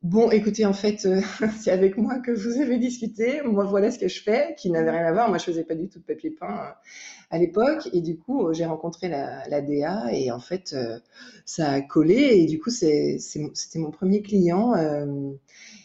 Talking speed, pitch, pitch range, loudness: 210 wpm, 185 Hz, 160-215 Hz, -24 LUFS